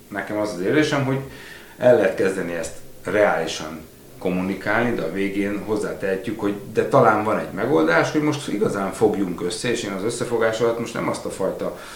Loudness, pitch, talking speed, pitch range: -22 LUFS, 100 Hz, 180 wpm, 95-115 Hz